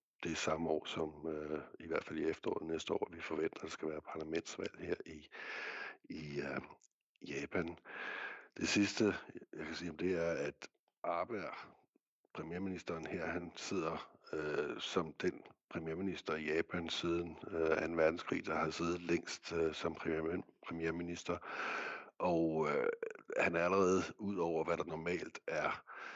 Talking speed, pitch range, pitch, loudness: 155 wpm, 80-90 Hz, 80 Hz, -40 LUFS